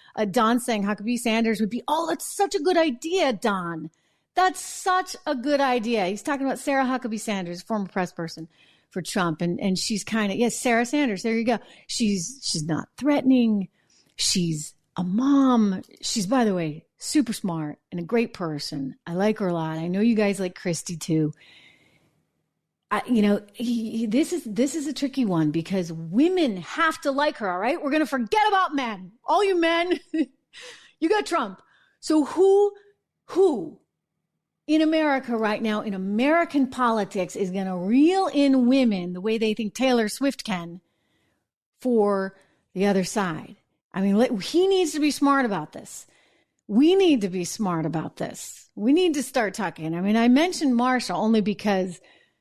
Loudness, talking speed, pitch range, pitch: -24 LUFS, 180 wpm, 190-285 Hz, 230 Hz